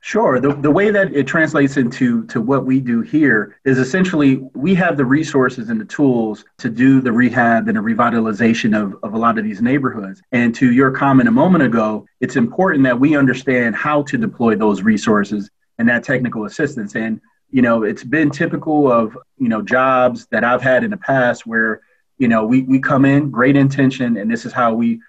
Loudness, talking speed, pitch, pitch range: -15 LUFS, 210 wpm, 130 Hz, 120-155 Hz